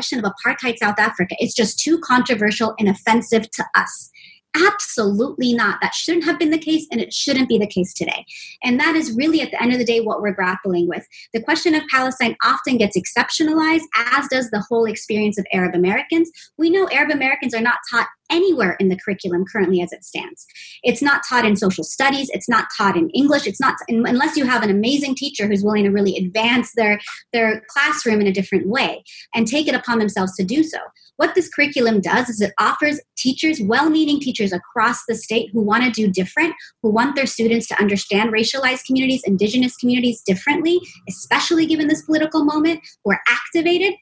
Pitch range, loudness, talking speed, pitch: 210-295 Hz, -18 LUFS, 200 wpm, 240 Hz